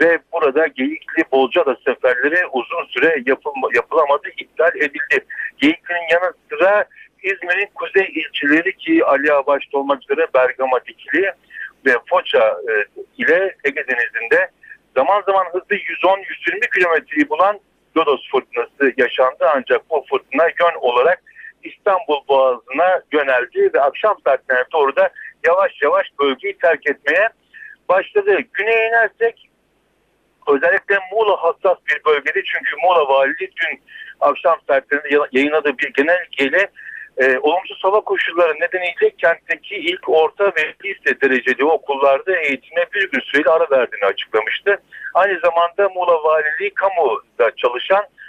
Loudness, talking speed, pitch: -17 LUFS, 125 wpm, 190 Hz